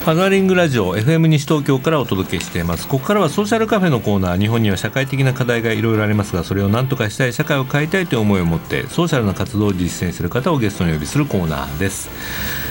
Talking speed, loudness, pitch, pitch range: 550 characters per minute, -17 LUFS, 115 Hz, 95-155 Hz